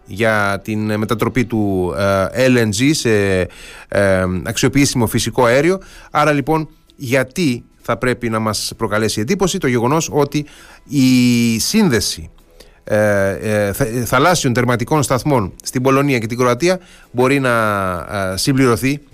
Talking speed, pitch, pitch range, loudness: 105 wpm, 120 Hz, 105-140 Hz, -16 LUFS